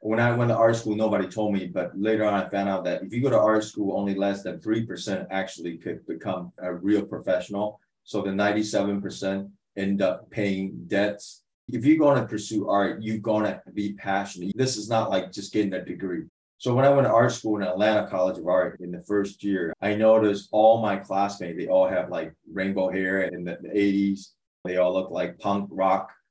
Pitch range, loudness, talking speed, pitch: 95-110 Hz, -25 LUFS, 215 wpm, 100 Hz